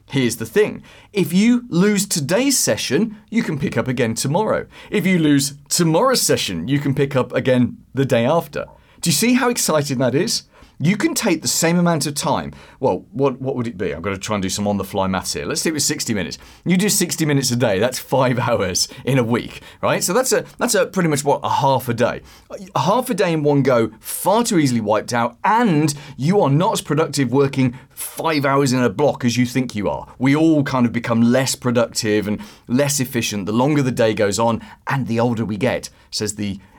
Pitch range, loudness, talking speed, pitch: 120-170 Hz, -18 LUFS, 230 wpm, 140 Hz